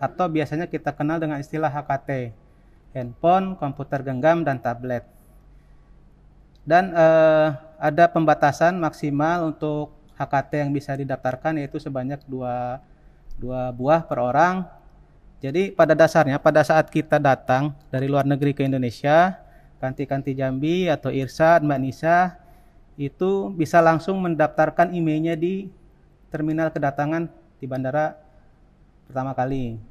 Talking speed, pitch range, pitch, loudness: 120 wpm, 135-160 Hz, 150 Hz, -22 LUFS